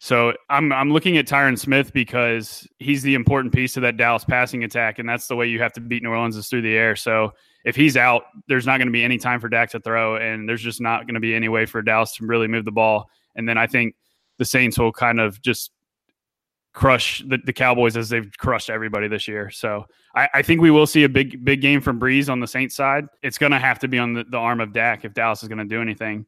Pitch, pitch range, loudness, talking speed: 120 Hz, 115-130 Hz, -19 LUFS, 270 wpm